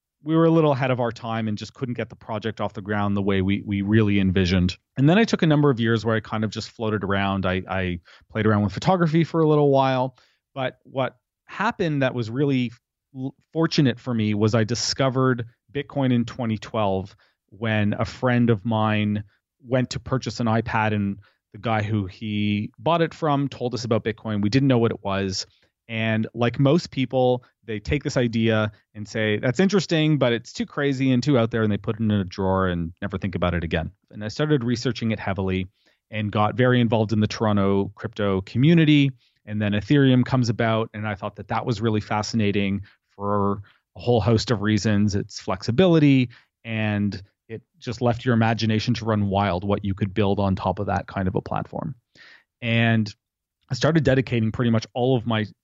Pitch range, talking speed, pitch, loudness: 105-130 Hz, 205 wpm, 110 Hz, -23 LUFS